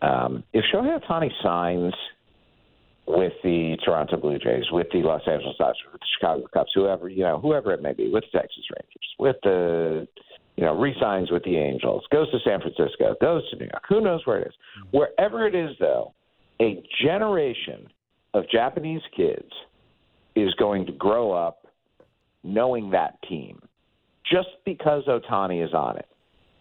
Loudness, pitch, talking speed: -24 LUFS, 100 Hz, 170 wpm